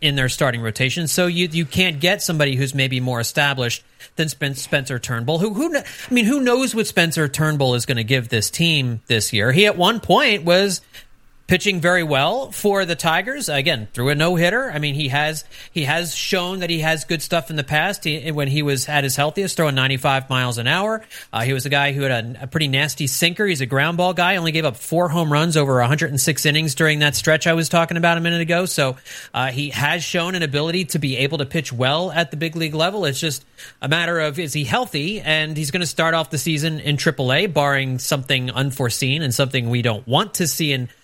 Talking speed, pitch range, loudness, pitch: 235 wpm, 135-170 Hz, -19 LUFS, 155 Hz